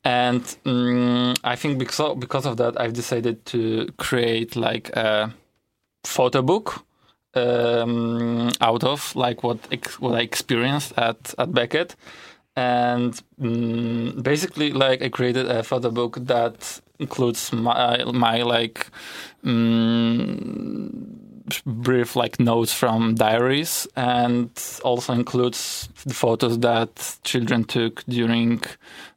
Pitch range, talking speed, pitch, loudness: 115-125 Hz, 120 wpm, 120 Hz, -22 LUFS